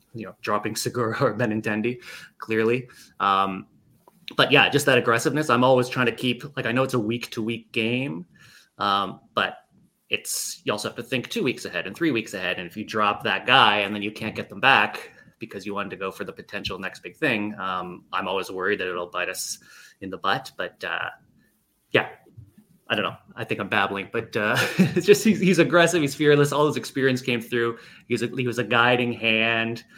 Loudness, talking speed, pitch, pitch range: -23 LUFS, 210 wpm, 120 Hz, 110-130 Hz